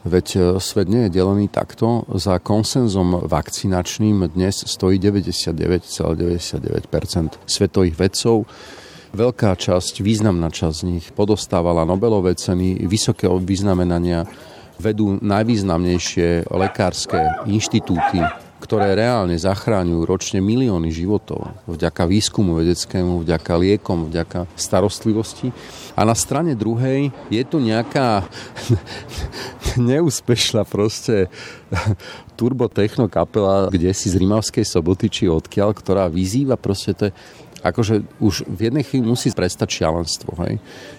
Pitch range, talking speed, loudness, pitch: 90-110 Hz, 105 wpm, -19 LUFS, 100 Hz